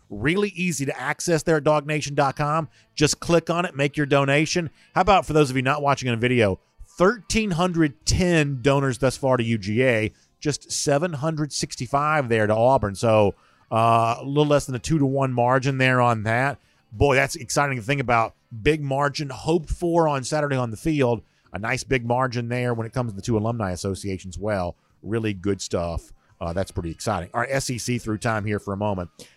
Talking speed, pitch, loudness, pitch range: 195 wpm, 130 Hz, -23 LUFS, 110-150 Hz